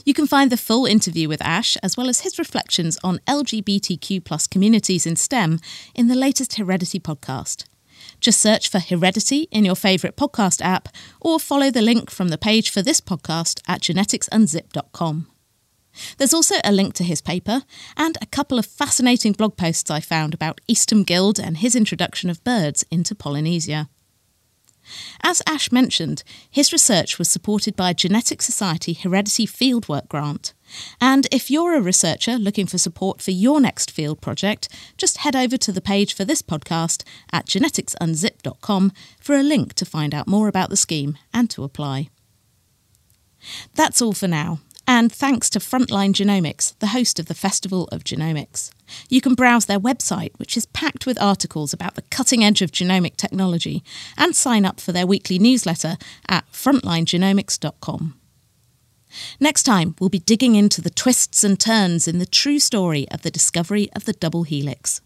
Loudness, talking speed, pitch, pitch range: -19 LUFS, 170 wpm, 195 Hz, 165-240 Hz